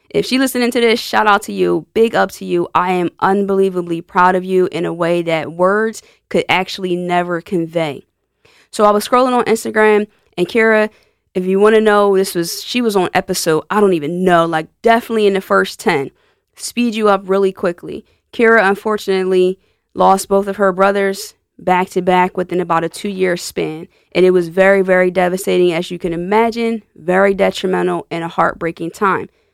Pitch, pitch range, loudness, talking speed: 190 Hz, 180-210 Hz, -15 LUFS, 190 wpm